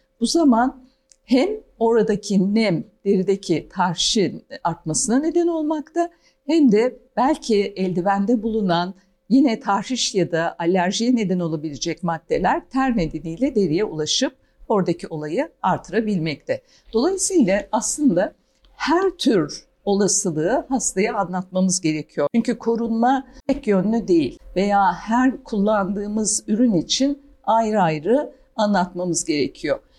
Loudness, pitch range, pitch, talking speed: -21 LUFS, 185-265 Hz, 215 Hz, 105 wpm